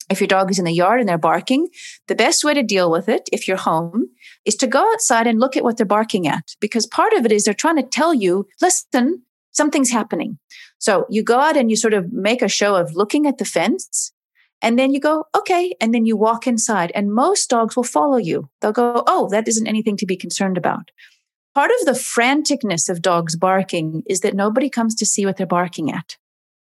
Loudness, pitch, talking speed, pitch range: -18 LUFS, 225 Hz, 230 wpm, 195-270 Hz